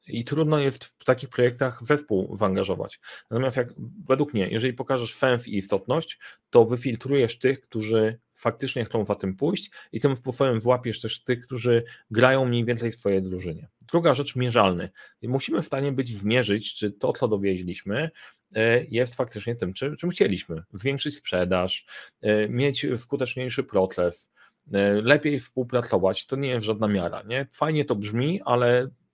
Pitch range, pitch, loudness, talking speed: 105-135 Hz, 120 Hz, -25 LUFS, 150 wpm